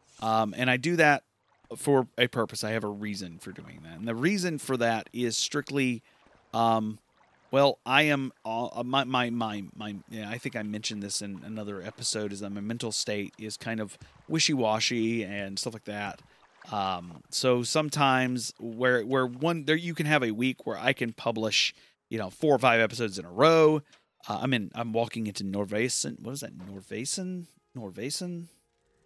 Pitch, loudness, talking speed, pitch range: 115 Hz, -28 LUFS, 190 wpm, 105-135 Hz